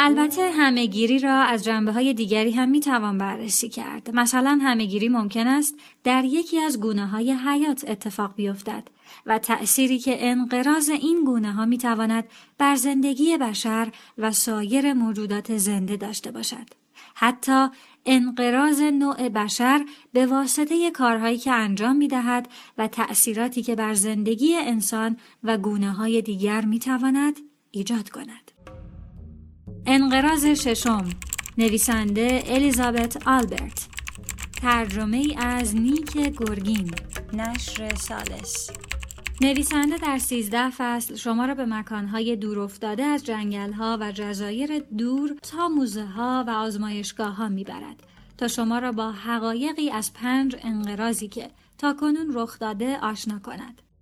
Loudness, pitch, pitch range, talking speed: -23 LUFS, 235 Hz, 215-265 Hz, 125 wpm